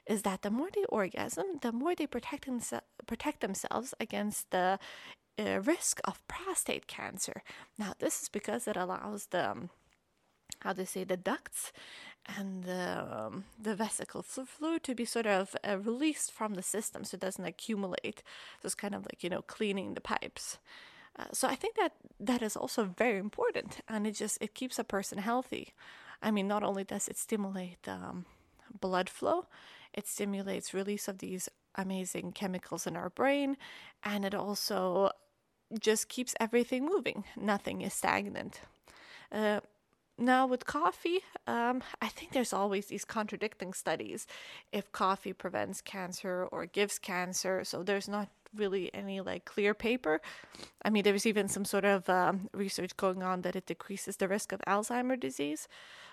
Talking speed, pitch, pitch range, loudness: 170 wpm, 205 Hz, 190-245 Hz, -35 LUFS